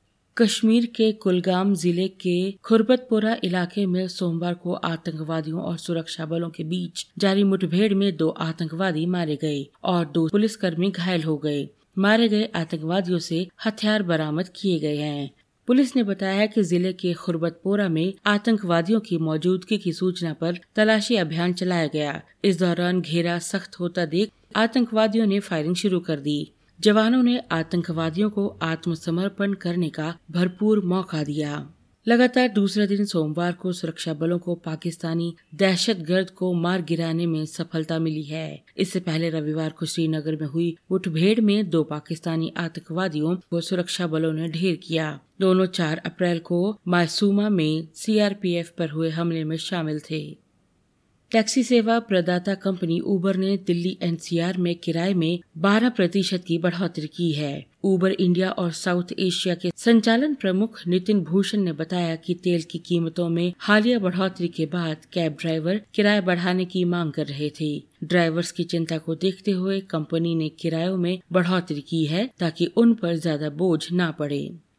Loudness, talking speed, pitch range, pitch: -23 LUFS, 155 wpm, 165-195 Hz, 175 Hz